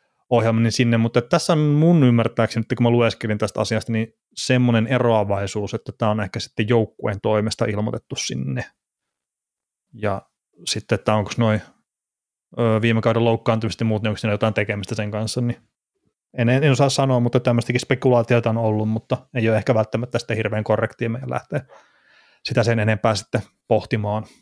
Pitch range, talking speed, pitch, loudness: 110-120 Hz, 160 wpm, 115 Hz, -21 LUFS